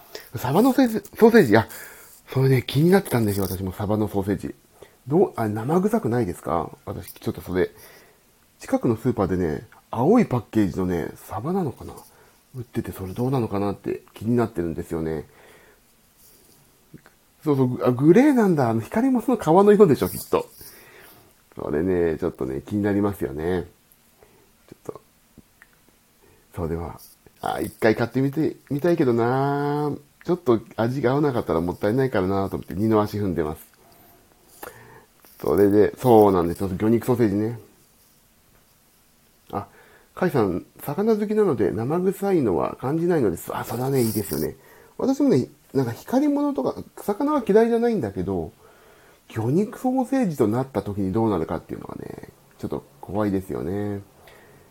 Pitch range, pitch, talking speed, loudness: 95-160 Hz, 115 Hz, 345 characters per minute, -22 LUFS